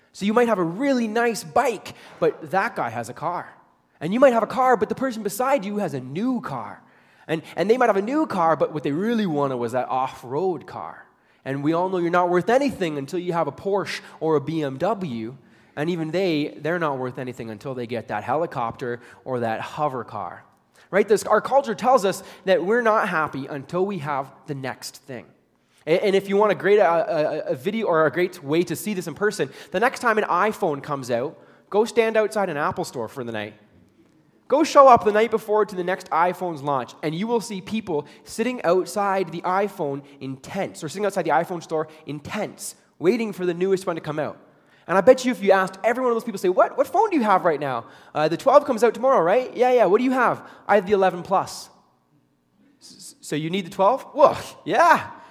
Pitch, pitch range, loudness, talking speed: 180 Hz, 150-215 Hz, -22 LUFS, 230 wpm